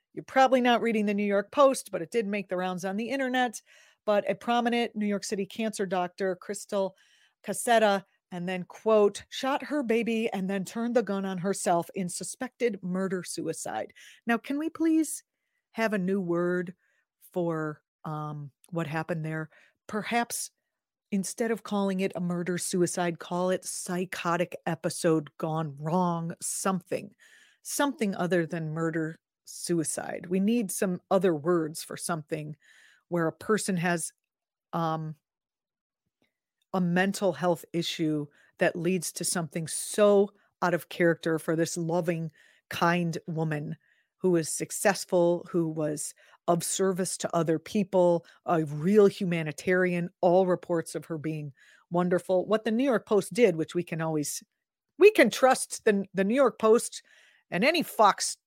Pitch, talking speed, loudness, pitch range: 185 Hz, 150 wpm, -28 LUFS, 170-210 Hz